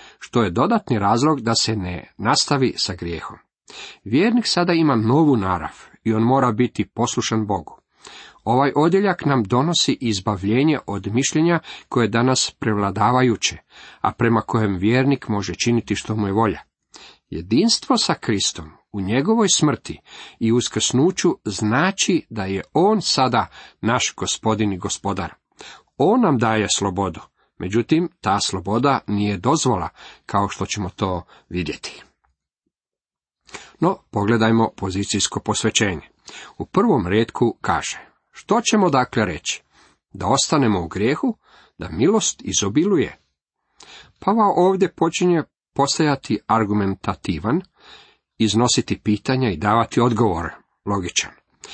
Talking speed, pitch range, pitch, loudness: 120 wpm, 100-135 Hz, 115 Hz, -20 LUFS